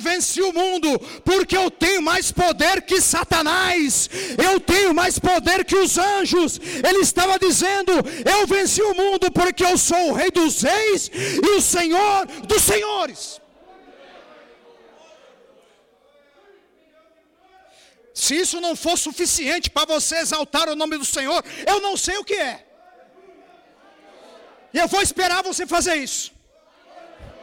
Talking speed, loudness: 135 wpm, -18 LUFS